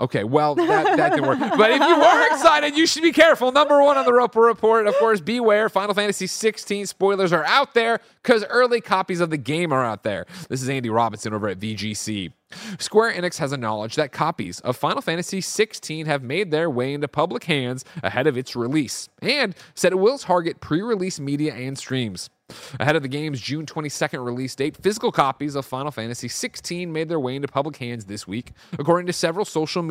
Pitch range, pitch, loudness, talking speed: 130-210 Hz, 160 Hz, -21 LUFS, 215 wpm